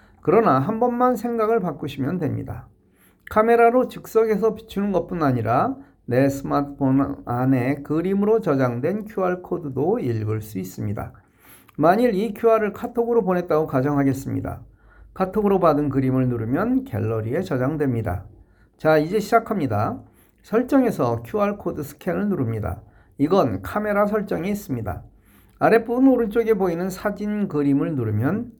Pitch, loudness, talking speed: 155 Hz, -22 LUFS, 325 characters per minute